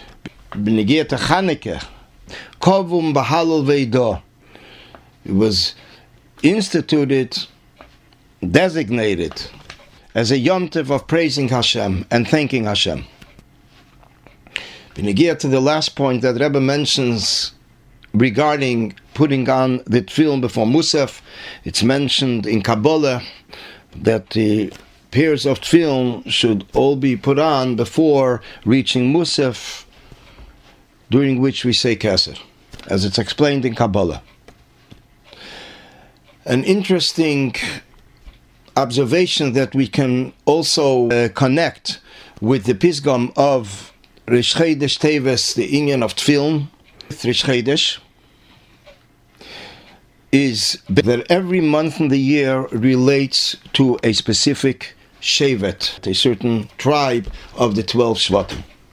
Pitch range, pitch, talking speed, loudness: 115-145 Hz, 130 Hz, 95 wpm, -17 LUFS